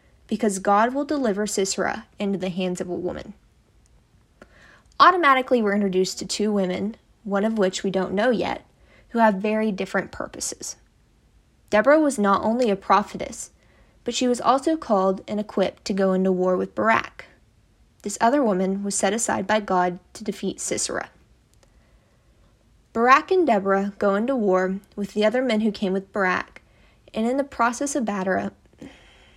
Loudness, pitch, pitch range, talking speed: -22 LUFS, 205 Hz, 190-230 Hz, 160 wpm